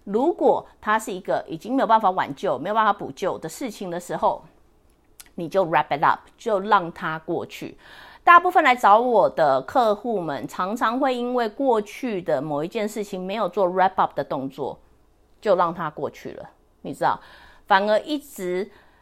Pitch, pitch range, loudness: 210 Hz, 185-245 Hz, -22 LUFS